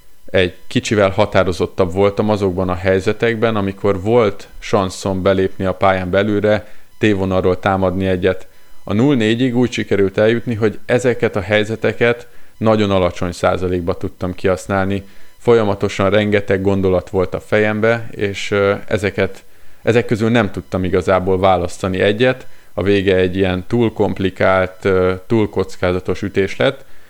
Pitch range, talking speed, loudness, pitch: 95-110 Hz, 125 wpm, -16 LUFS, 100 Hz